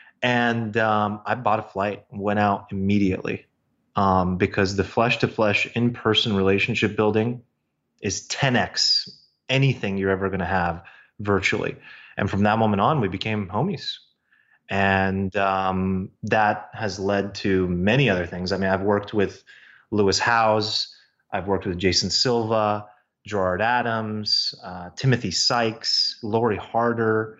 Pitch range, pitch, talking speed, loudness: 95-110 Hz, 105 Hz, 140 wpm, -22 LUFS